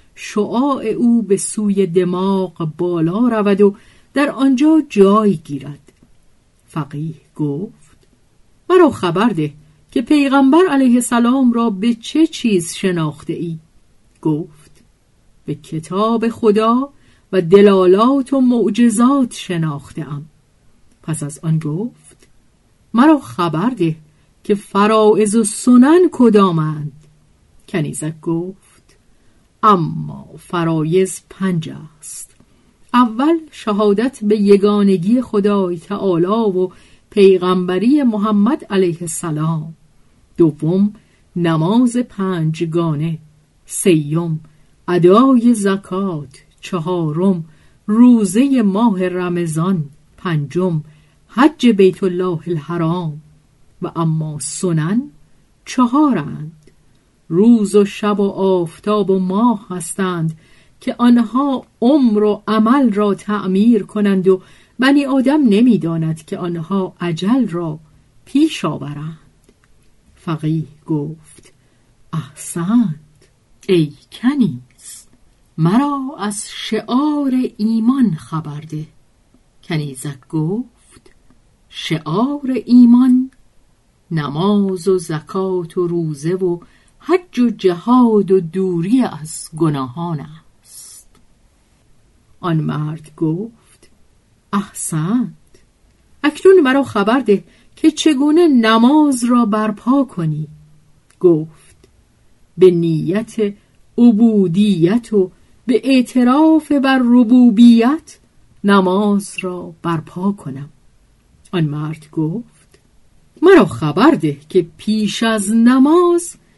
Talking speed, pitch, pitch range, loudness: 90 wpm, 190 Hz, 160-235 Hz, -15 LUFS